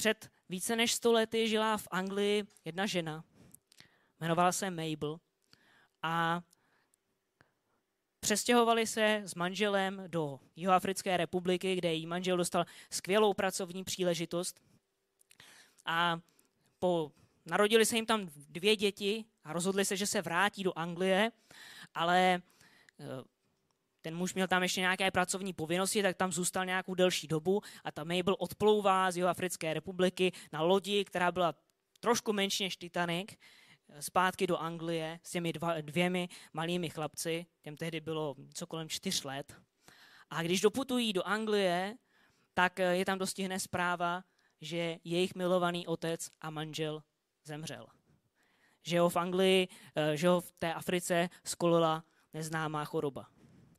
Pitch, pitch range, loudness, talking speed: 180 Hz, 165-195 Hz, -33 LUFS, 130 wpm